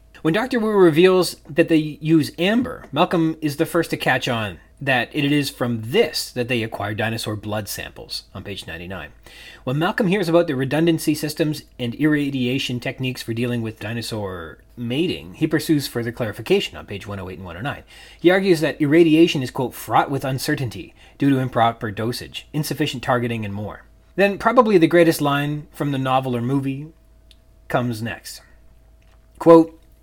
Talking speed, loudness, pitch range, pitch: 165 wpm, -20 LUFS, 115-160 Hz, 135 Hz